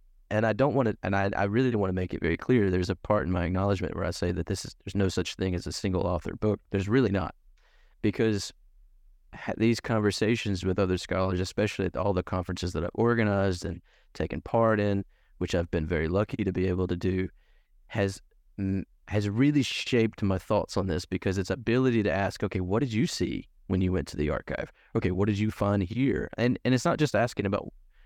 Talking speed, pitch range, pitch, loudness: 225 wpm, 90-110 Hz, 100 Hz, -28 LUFS